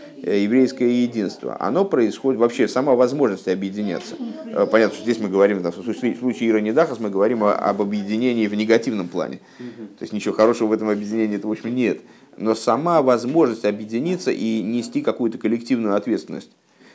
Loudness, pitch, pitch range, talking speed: -20 LUFS, 110 Hz, 105-120 Hz, 150 wpm